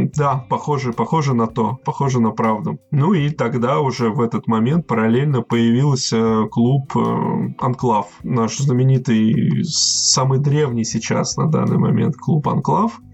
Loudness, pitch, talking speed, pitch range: -18 LUFS, 120 Hz, 130 wpm, 115-140 Hz